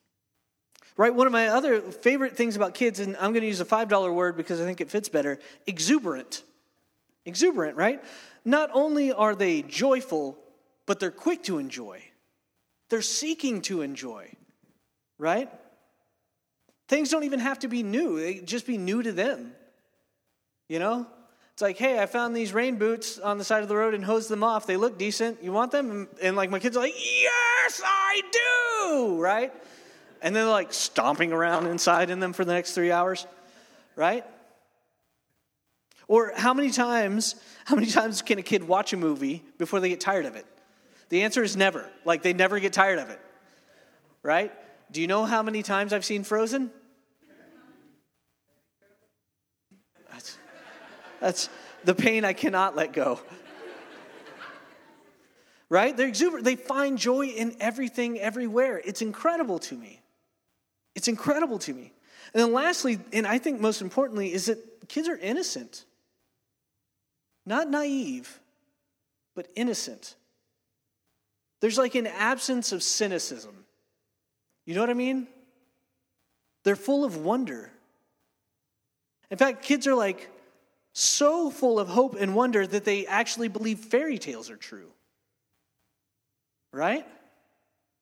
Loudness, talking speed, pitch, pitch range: -26 LUFS, 150 wpm, 230 Hz, 200-270 Hz